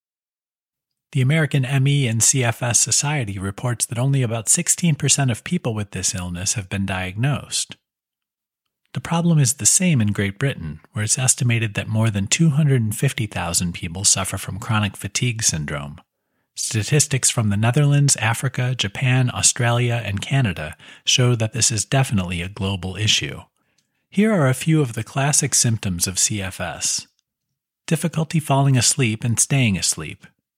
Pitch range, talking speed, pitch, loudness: 100-140 Hz, 145 wpm, 120 Hz, -19 LUFS